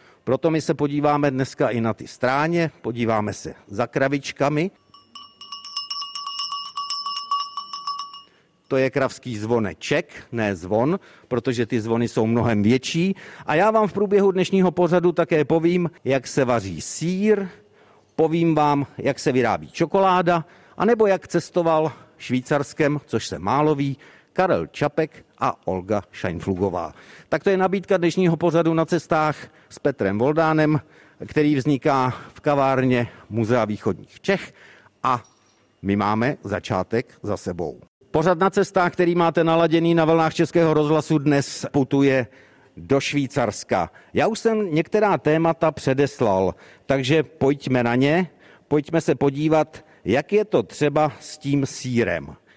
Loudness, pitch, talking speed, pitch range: -22 LUFS, 150 Hz, 130 wpm, 125-175 Hz